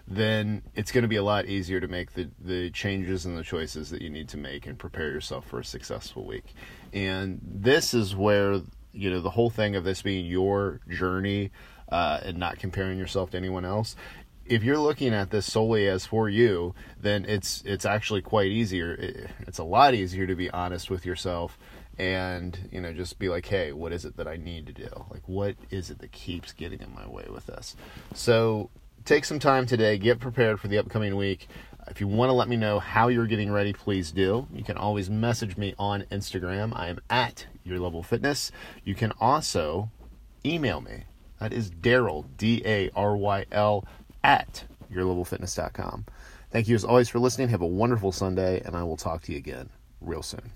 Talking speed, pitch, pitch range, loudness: 205 wpm, 100 Hz, 90-110 Hz, -27 LUFS